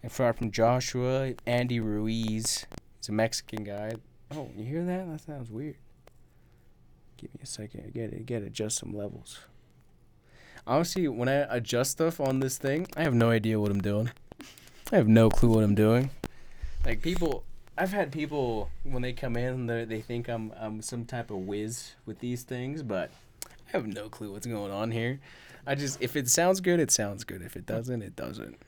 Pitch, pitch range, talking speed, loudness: 120 Hz, 110-135 Hz, 195 wpm, -30 LUFS